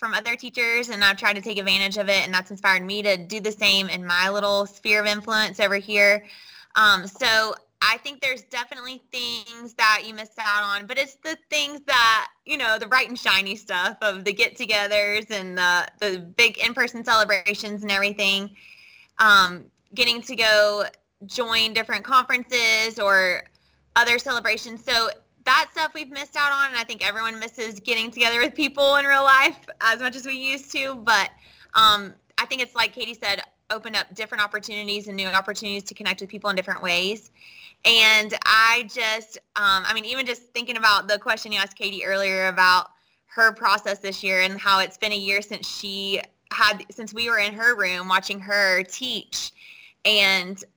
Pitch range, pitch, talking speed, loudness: 200-235 Hz, 215 Hz, 190 wpm, -21 LUFS